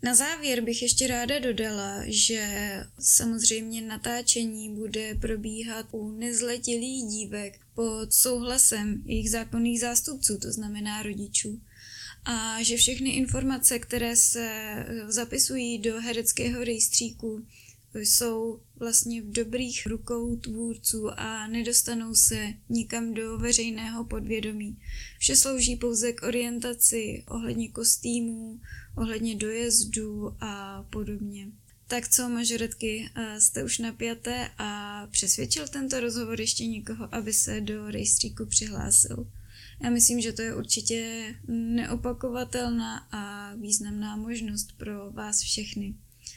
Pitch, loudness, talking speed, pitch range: 225 Hz, -26 LUFS, 110 wpm, 210-235 Hz